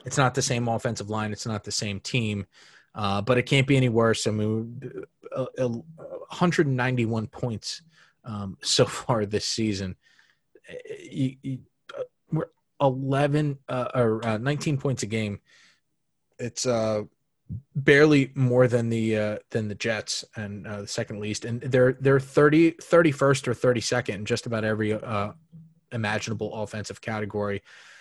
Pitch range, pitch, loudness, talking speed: 110-140 Hz, 120 Hz, -25 LUFS, 140 wpm